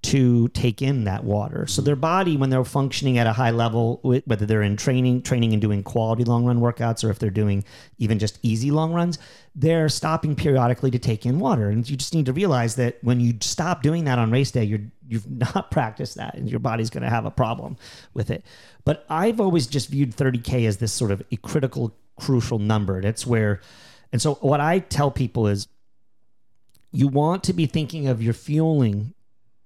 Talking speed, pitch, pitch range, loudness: 210 wpm, 120 Hz, 115-140 Hz, -22 LUFS